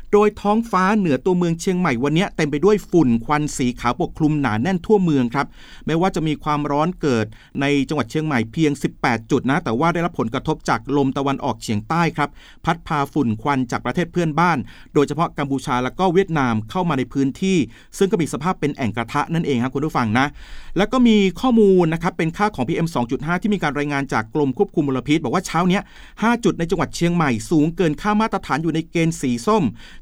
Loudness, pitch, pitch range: -20 LUFS, 155 Hz, 140-180 Hz